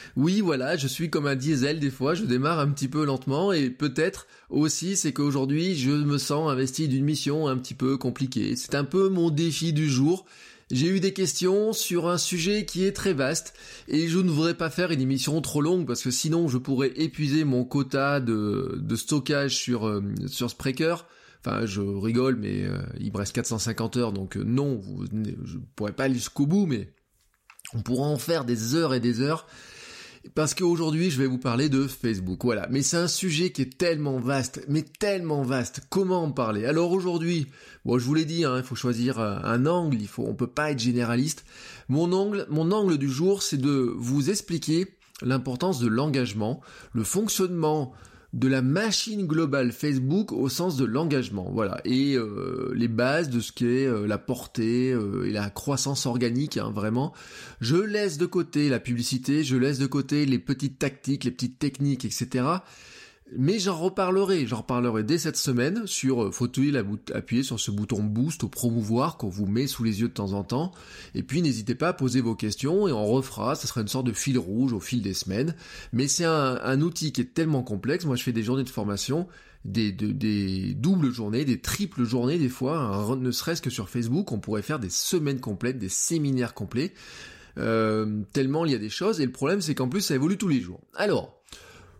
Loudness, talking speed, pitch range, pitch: -26 LUFS, 205 wpm, 120-160 Hz, 135 Hz